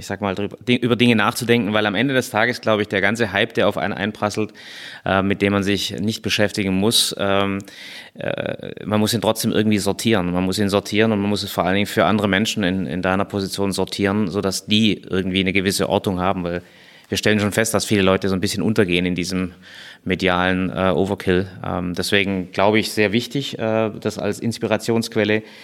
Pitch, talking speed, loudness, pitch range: 100 Hz, 190 wpm, -20 LUFS, 95-110 Hz